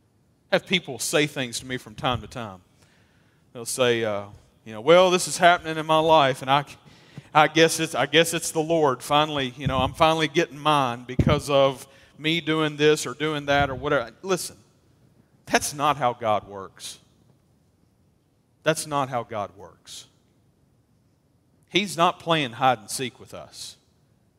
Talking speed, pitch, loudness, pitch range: 165 wpm, 140 Hz, -23 LUFS, 125-155 Hz